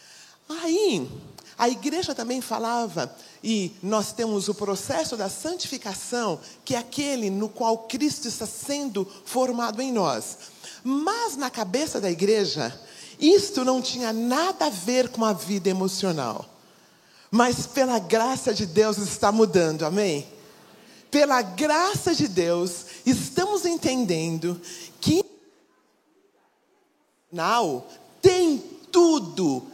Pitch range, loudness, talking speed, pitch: 205-290 Hz, -24 LUFS, 115 wpm, 235 Hz